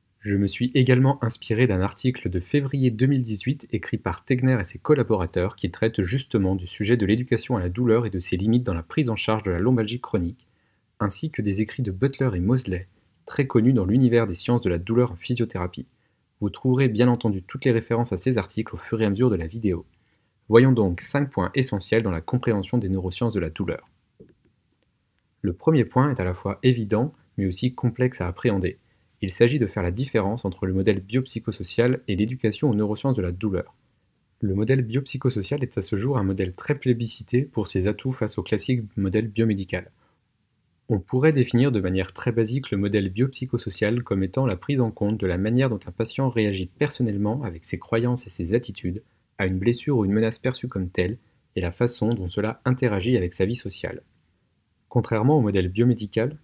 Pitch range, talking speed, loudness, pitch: 100-125 Hz, 205 wpm, -24 LUFS, 110 Hz